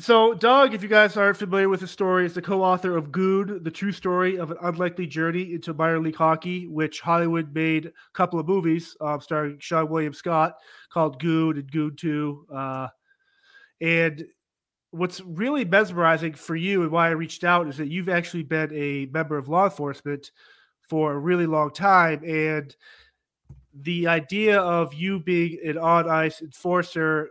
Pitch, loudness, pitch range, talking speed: 165 Hz, -23 LUFS, 155-185 Hz, 180 wpm